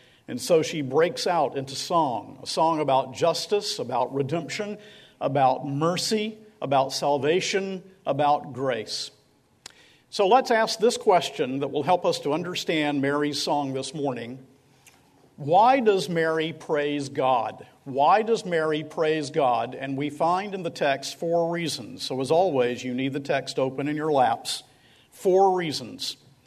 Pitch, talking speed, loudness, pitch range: 150 Hz, 145 wpm, -25 LUFS, 140-185 Hz